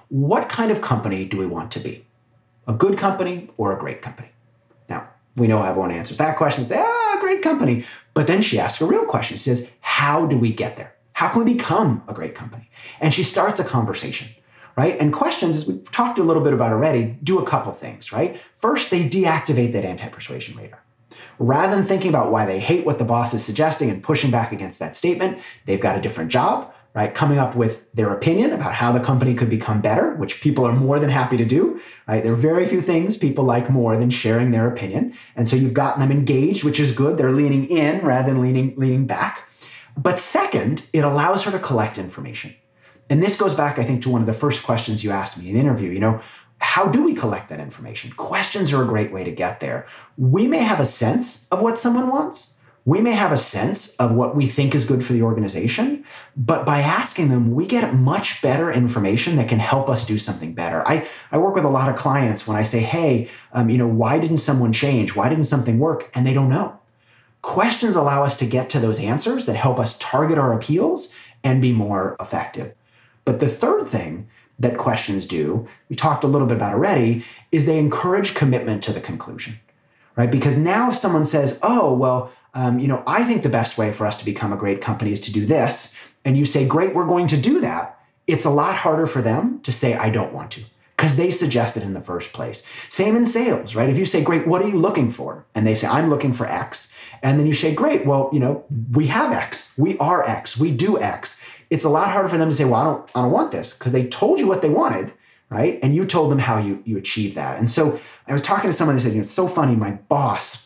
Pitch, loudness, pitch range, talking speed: 130 Hz, -20 LUFS, 115-155 Hz, 235 wpm